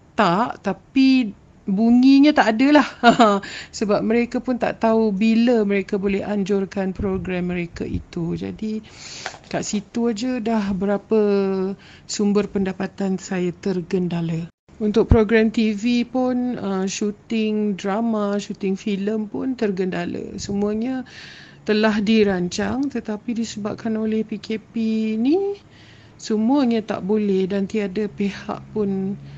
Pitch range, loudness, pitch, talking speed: 195-230 Hz, -21 LUFS, 210 Hz, 110 wpm